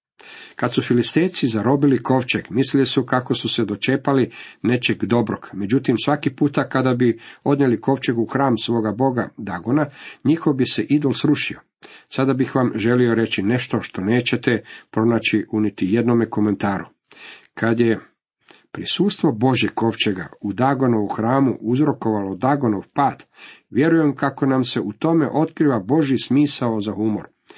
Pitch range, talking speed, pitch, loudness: 115-140 Hz, 140 wpm, 125 Hz, -20 LUFS